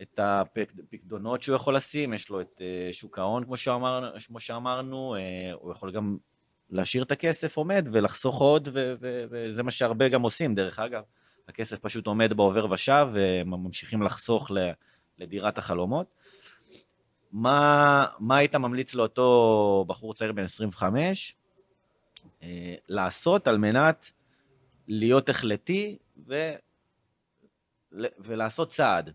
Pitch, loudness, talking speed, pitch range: 115 Hz, -26 LUFS, 115 wpm, 105-135 Hz